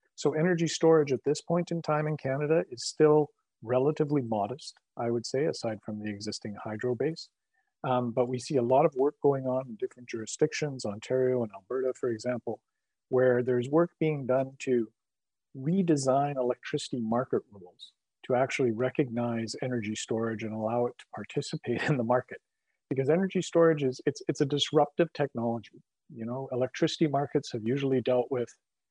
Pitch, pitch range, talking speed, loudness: 130 Hz, 120-150 Hz, 170 wpm, -29 LUFS